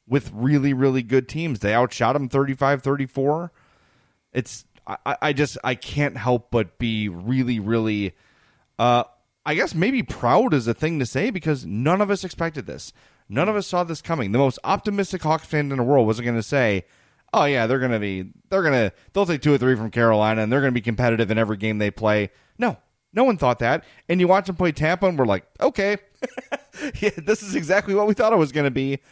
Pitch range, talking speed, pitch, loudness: 120-170 Hz, 215 wpm, 135 Hz, -22 LUFS